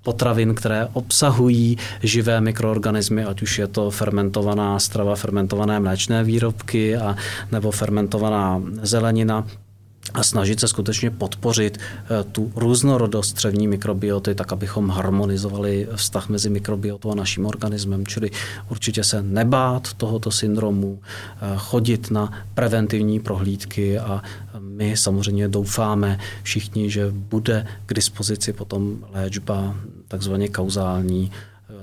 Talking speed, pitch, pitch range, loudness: 110 wpm, 105 Hz, 100-110 Hz, -21 LUFS